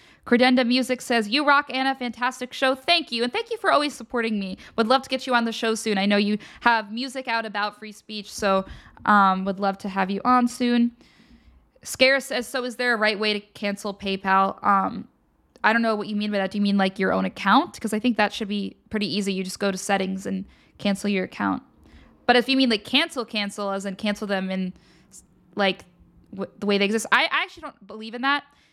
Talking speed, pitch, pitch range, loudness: 235 wpm, 215 Hz, 200-250 Hz, -23 LUFS